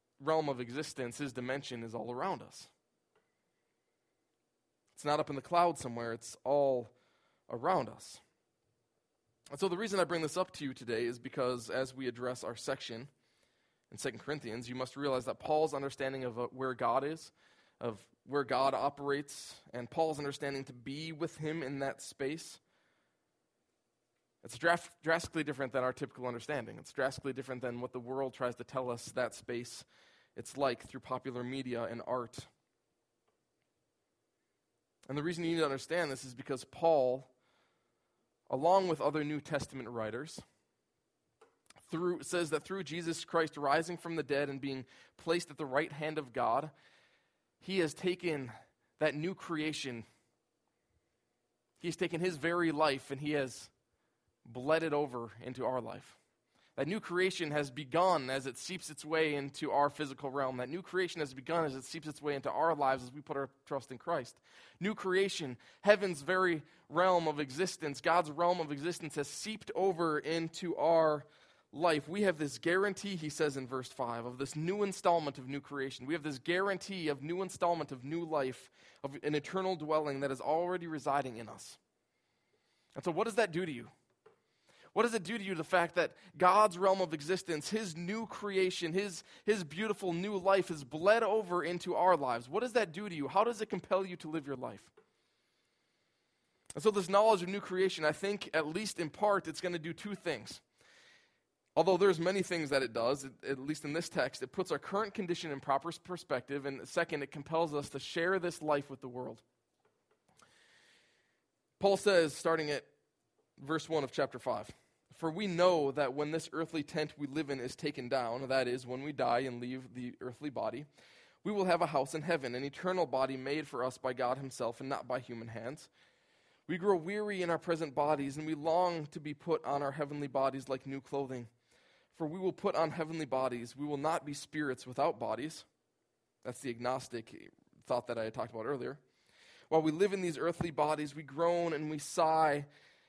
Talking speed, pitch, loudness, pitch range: 190 wpm, 150 Hz, -35 LUFS, 135-175 Hz